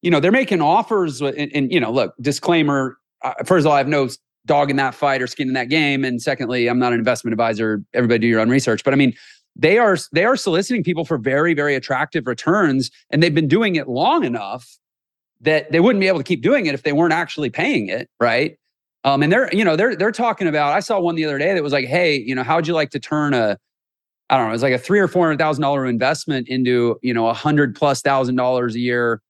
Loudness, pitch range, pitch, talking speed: -18 LUFS, 125-160 Hz, 140 Hz, 260 wpm